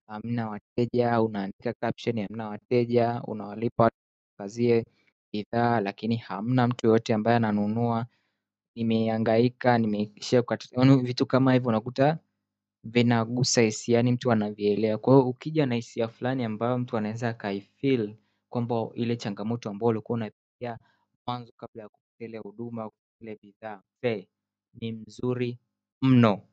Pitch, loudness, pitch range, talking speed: 115 Hz, -26 LUFS, 105-120 Hz, 115 wpm